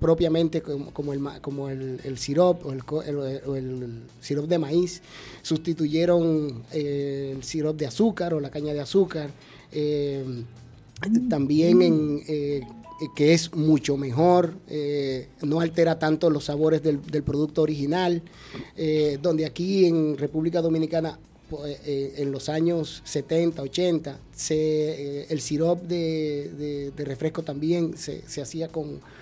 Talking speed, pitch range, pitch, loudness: 140 wpm, 140-165 Hz, 155 Hz, -25 LUFS